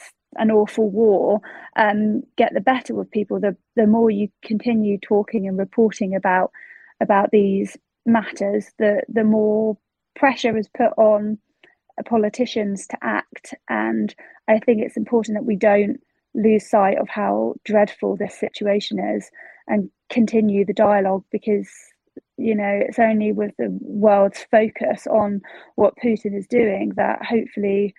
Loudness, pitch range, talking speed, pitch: -20 LUFS, 205-235 Hz, 145 wpm, 215 Hz